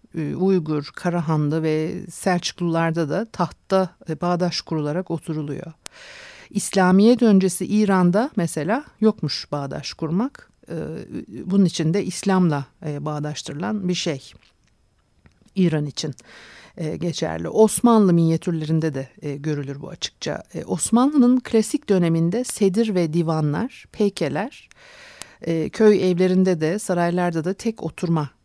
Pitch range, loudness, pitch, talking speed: 160-200 Hz, -21 LUFS, 175 Hz, 95 wpm